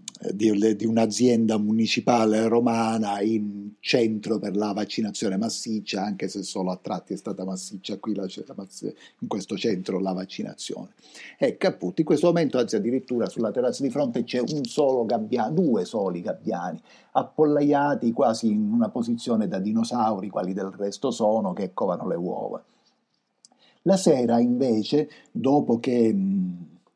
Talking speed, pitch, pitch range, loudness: 145 wpm, 115 Hz, 105-175 Hz, -25 LUFS